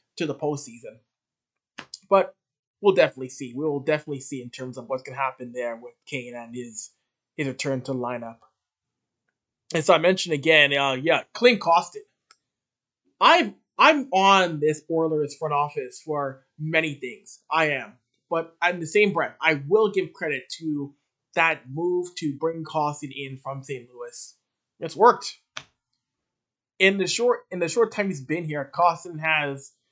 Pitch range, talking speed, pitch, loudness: 135-175 Hz, 165 wpm, 150 Hz, -23 LUFS